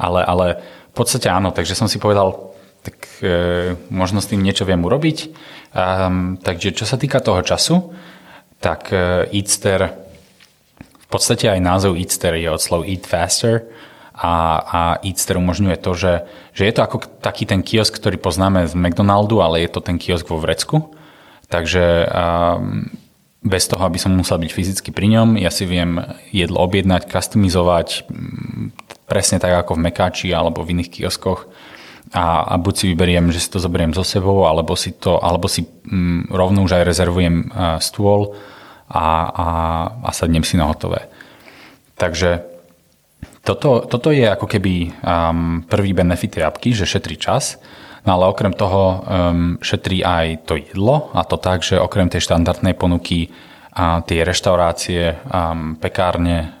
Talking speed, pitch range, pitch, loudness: 160 wpm, 85-100 Hz, 90 Hz, -17 LUFS